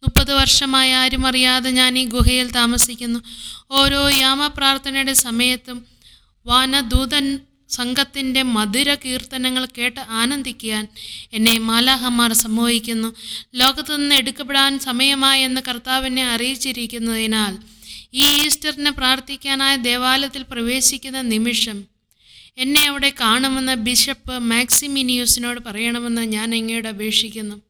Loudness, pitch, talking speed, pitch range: -17 LUFS, 255 Hz, 90 wpm, 235-270 Hz